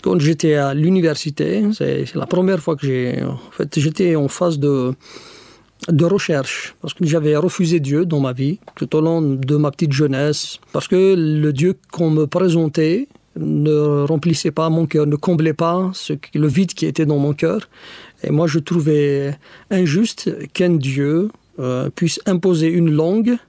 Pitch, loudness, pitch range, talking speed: 160 Hz, -18 LUFS, 150-180 Hz, 175 wpm